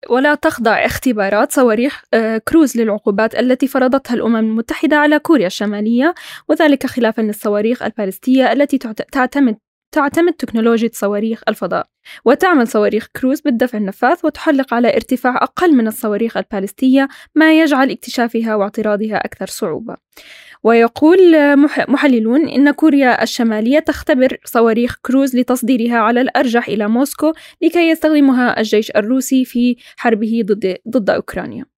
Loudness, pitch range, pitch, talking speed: -14 LUFS, 225-285 Hz, 250 Hz, 115 wpm